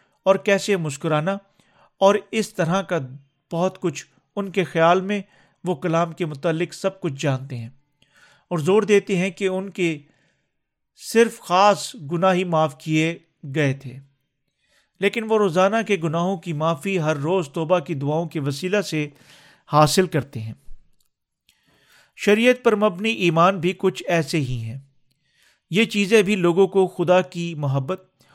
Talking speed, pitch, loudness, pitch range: 150 wpm, 175 Hz, -21 LUFS, 150-195 Hz